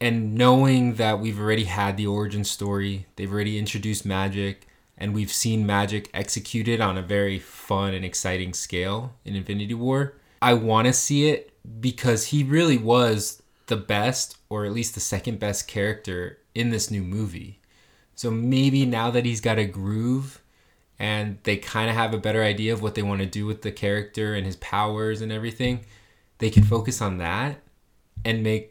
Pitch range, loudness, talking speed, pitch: 100-115 Hz, -24 LUFS, 180 wpm, 105 Hz